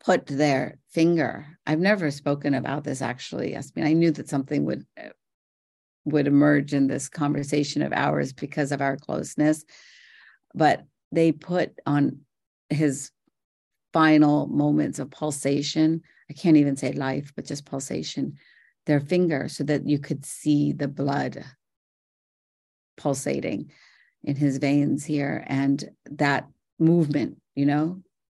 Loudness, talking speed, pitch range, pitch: -24 LUFS, 135 wpm, 140-155 Hz, 145 Hz